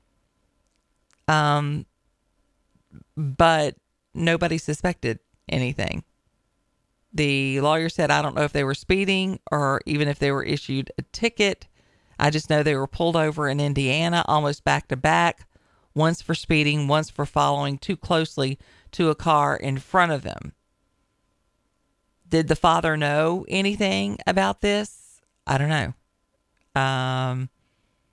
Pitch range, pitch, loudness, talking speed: 135-160 Hz, 150 Hz, -23 LUFS, 130 wpm